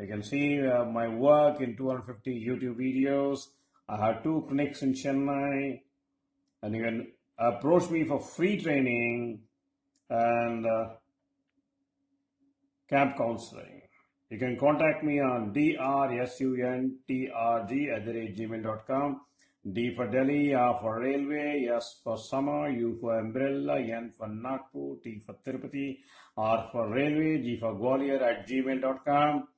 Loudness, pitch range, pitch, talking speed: -30 LUFS, 115-145 Hz, 130 Hz, 125 wpm